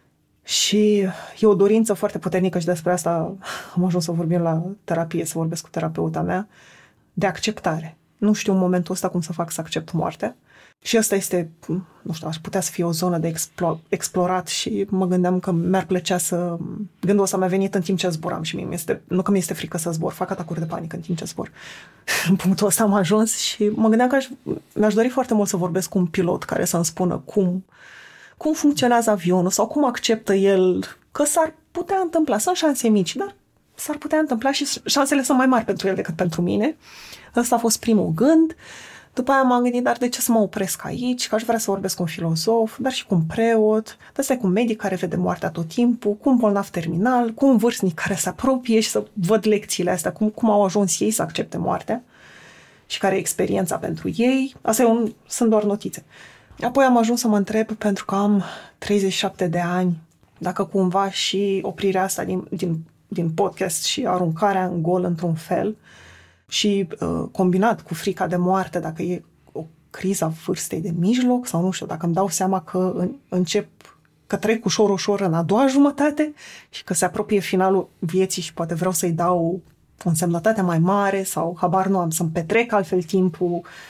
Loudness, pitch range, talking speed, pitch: -21 LUFS, 180-220 Hz, 200 wpm, 195 Hz